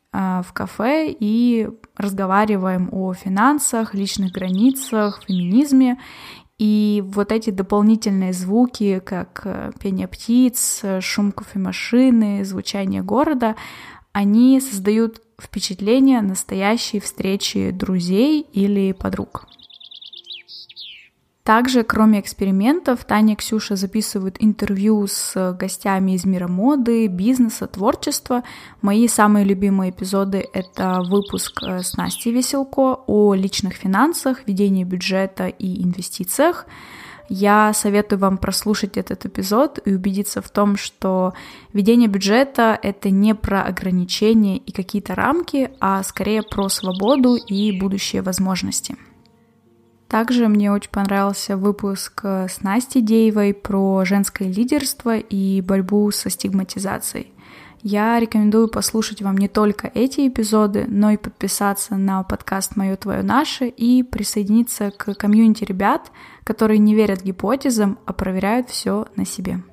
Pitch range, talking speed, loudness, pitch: 195-230 Hz, 115 wpm, -19 LUFS, 205 Hz